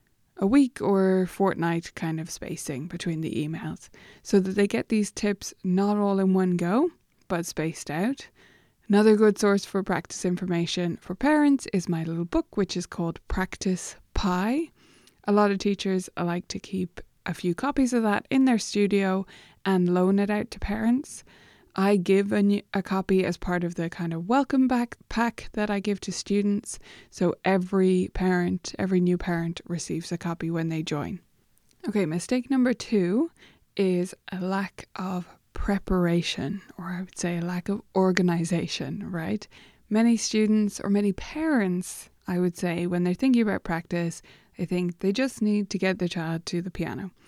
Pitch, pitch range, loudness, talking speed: 190 Hz, 175-205 Hz, -26 LUFS, 175 wpm